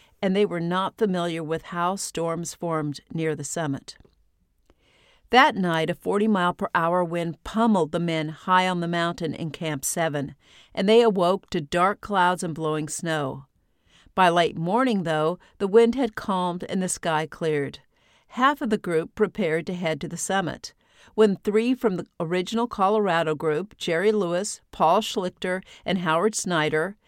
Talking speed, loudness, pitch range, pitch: 165 wpm, -24 LUFS, 160-200 Hz, 175 Hz